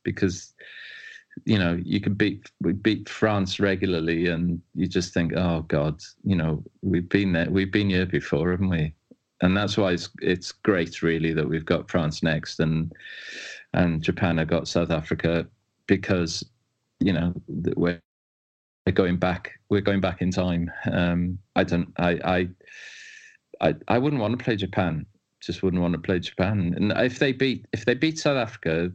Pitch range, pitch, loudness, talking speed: 85-105 Hz, 90 Hz, -25 LUFS, 175 wpm